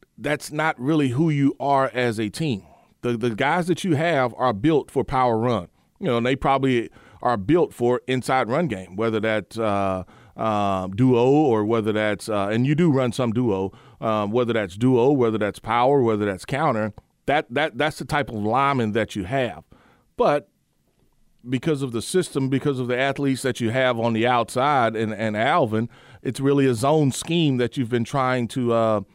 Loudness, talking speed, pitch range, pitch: -22 LUFS, 195 wpm, 110-140 Hz, 125 Hz